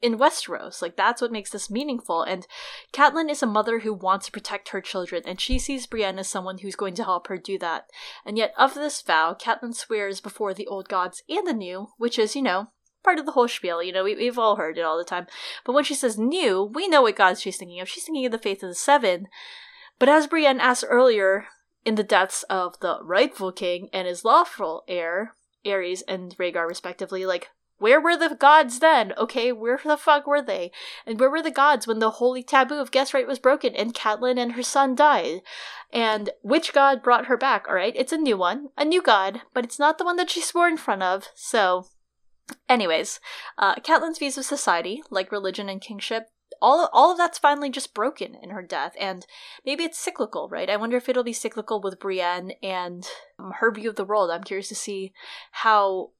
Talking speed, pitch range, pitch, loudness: 225 wpm, 195-285 Hz, 230 Hz, -23 LUFS